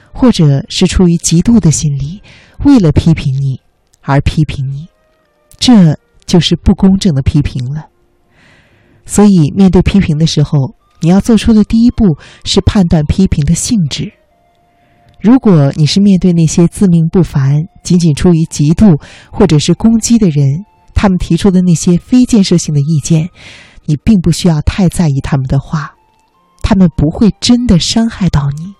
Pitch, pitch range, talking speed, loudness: 170 Hz, 150-200 Hz, 240 characters per minute, -10 LUFS